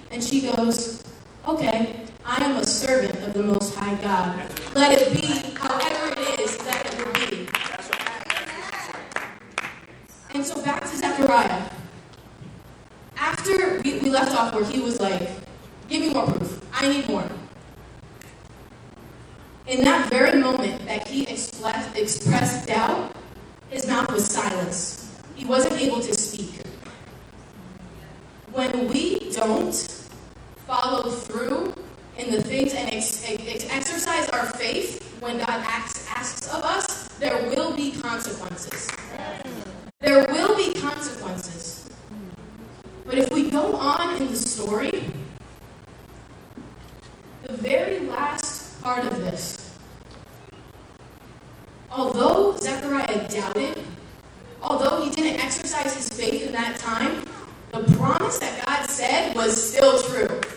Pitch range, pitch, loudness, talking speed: 220-275 Hz, 250 Hz, -24 LUFS, 120 wpm